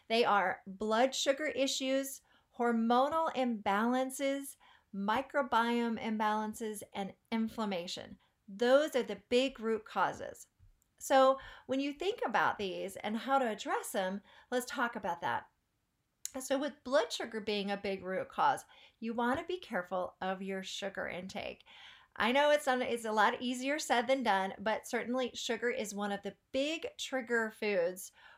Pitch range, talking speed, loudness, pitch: 205-265 Hz, 145 wpm, -34 LUFS, 235 Hz